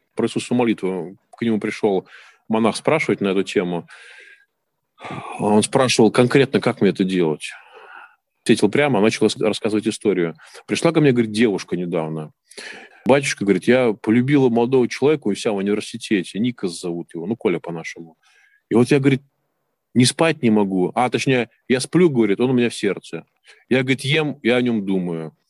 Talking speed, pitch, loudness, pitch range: 165 wpm, 115 Hz, -19 LUFS, 100-135 Hz